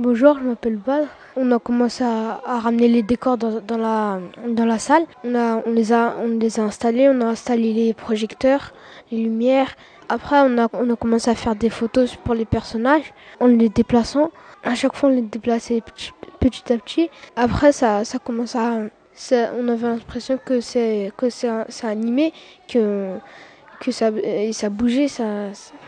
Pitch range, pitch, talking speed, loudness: 225-250 Hz, 235 Hz, 190 wpm, -20 LUFS